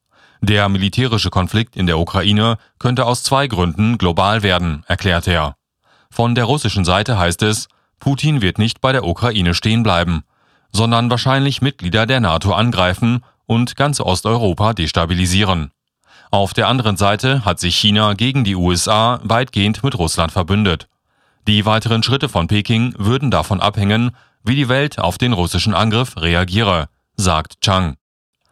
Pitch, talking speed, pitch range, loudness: 105 Hz, 145 wpm, 90-120 Hz, -16 LUFS